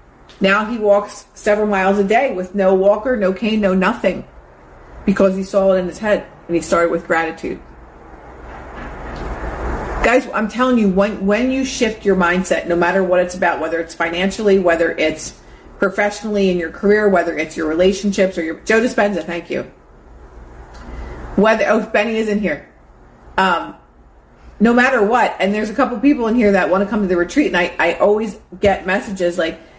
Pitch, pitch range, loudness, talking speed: 190 Hz, 170-210 Hz, -16 LUFS, 185 wpm